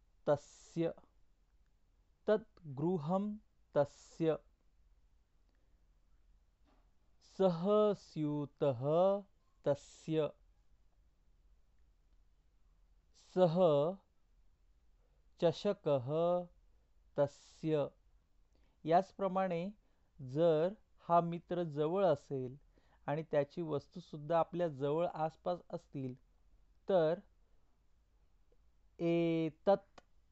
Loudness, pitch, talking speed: -36 LUFS, 145 Hz, 50 wpm